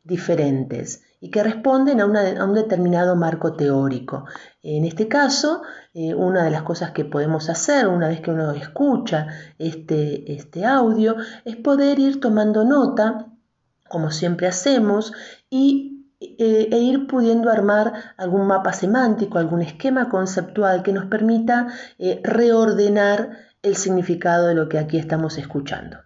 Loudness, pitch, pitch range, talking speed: -20 LUFS, 200 Hz, 165-230 Hz, 145 wpm